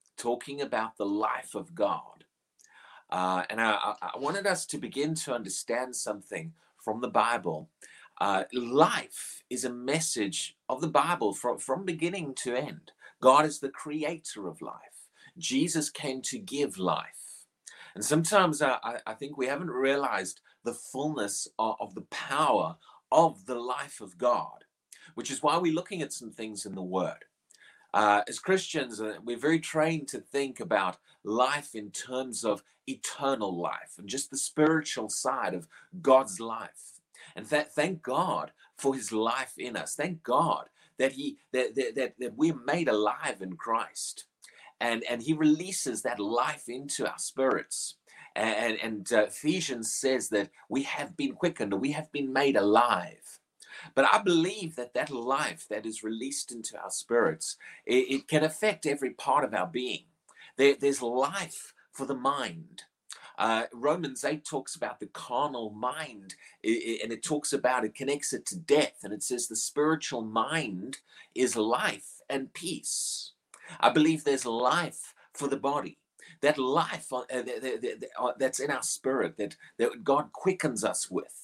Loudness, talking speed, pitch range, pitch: -30 LUFS, 160 wpm, 115-155 Hz, 135 Hz